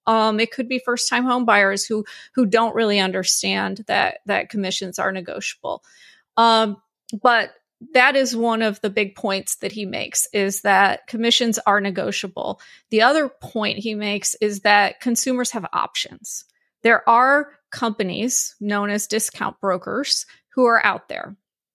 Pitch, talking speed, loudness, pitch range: 220 Hz, 150 wpm, -20 LUFS, 205-240 Hz